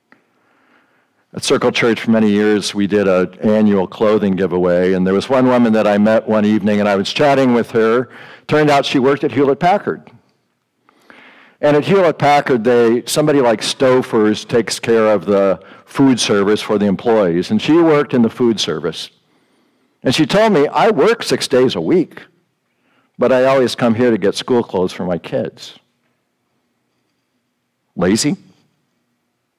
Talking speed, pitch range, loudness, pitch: 165 wpm, 105-135 Hz, -14 LUFS, 115 Hz